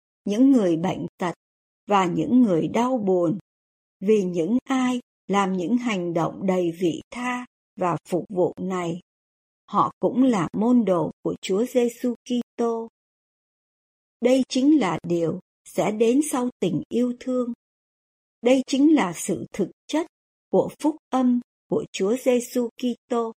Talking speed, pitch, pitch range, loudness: 140 wpm, 230 Hz, 180-250 Hz, -23 LUFS